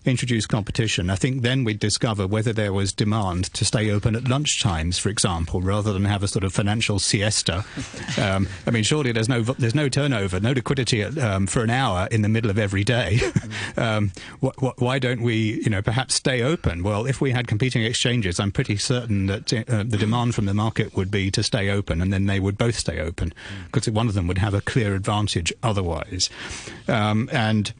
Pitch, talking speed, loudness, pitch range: 110 Hz, 205 wpm, -22 LUFS, 100-125 Hz